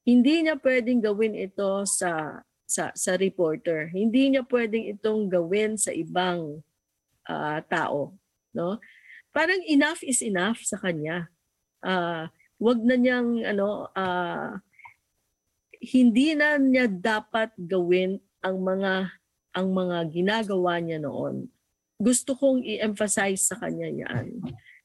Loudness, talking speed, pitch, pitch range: -25 LUFS, 120 wpm, 205 Hz, 180-245 Hz